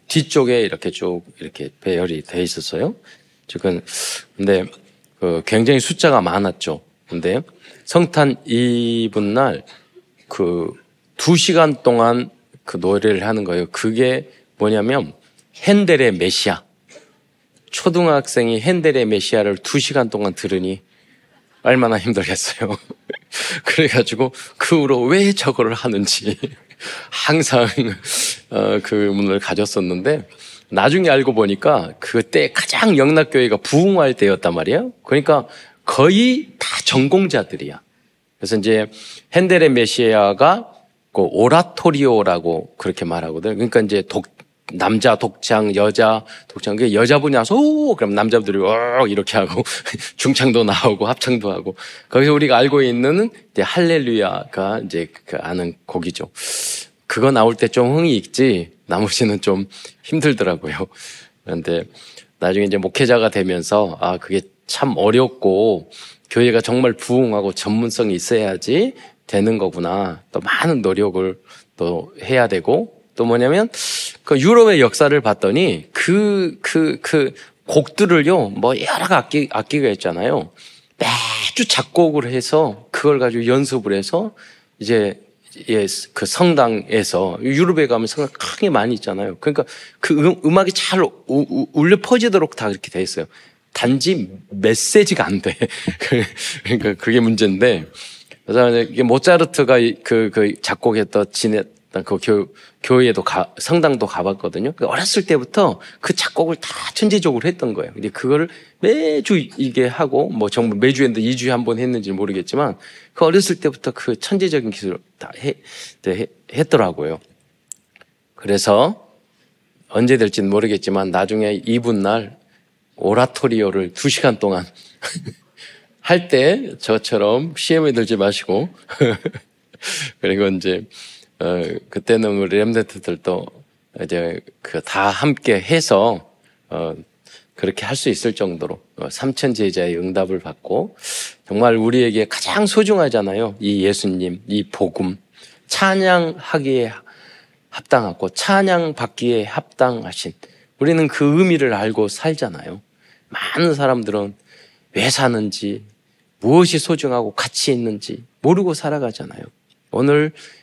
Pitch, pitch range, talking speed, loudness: 120 Hz, 100-150 Hz, 270 characters per minute, -17 LUFS